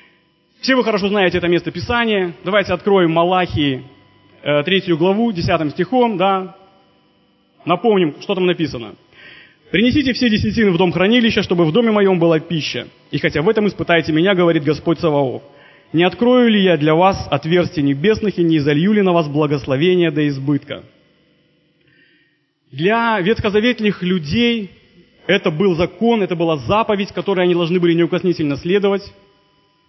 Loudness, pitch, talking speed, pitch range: -16 LUFS, 180 Hz, 145 wpm, 160-200 Hz